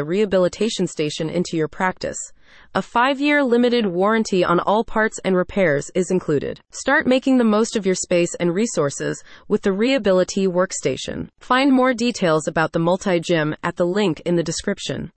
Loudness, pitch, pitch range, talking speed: -20 LUFS, 185 Hz, 175-225 Hz, 165 wpm